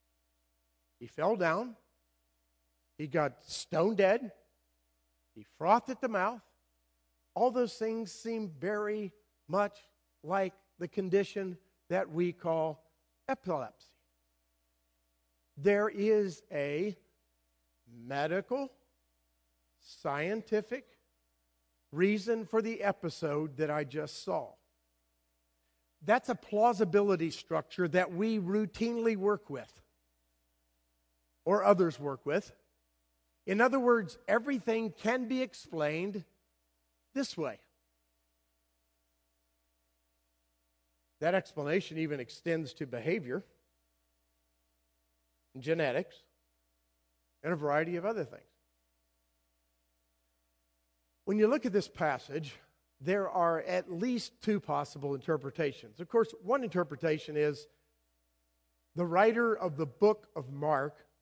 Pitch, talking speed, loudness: 145 Hz, 95 wpm, -33 LUFS